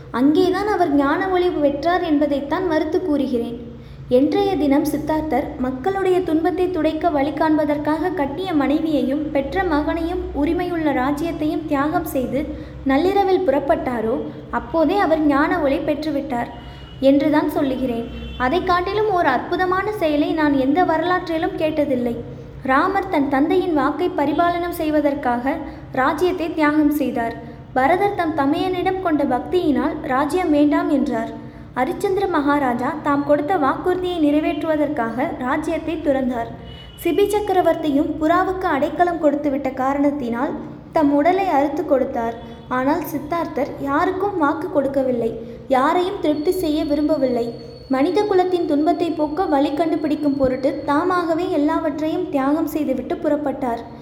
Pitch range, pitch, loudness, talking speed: 280-345 Hz, 305 Hz, -20 LUFS, 110 wpm